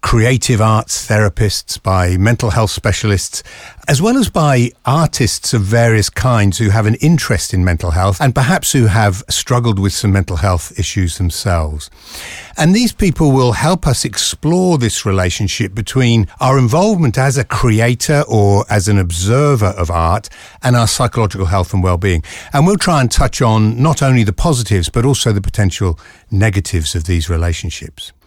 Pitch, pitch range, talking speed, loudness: 110 Hz, 95-130 Hz, 165 wpm, -13 LUFS